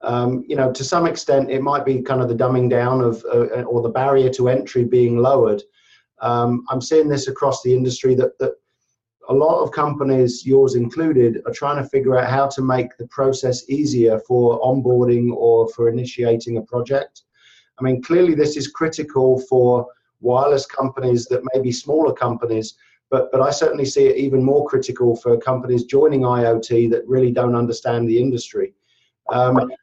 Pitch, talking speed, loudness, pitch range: 130 Hz, 180 wpm, -18 LUFS, 120-135 Hz